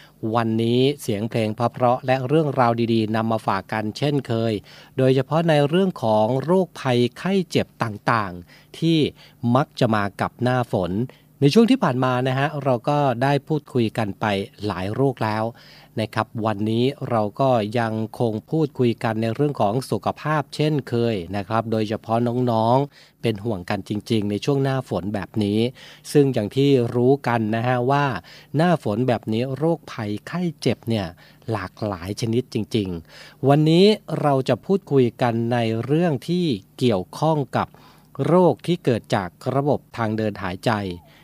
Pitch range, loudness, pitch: 110-140 Hz, -22 LUFS, 125 Hz